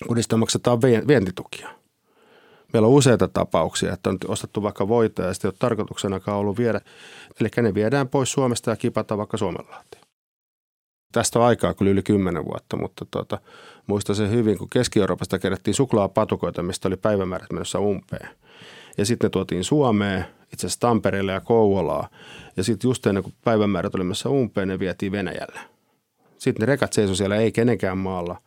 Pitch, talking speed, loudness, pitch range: 105 Hz, 160 wpm, -22 LUFS, 95-115 Hz